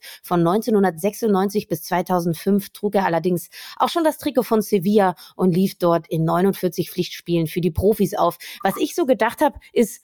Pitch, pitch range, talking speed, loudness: 195 Hz, 175-220 Hz, 175 wpm, -21 LUFS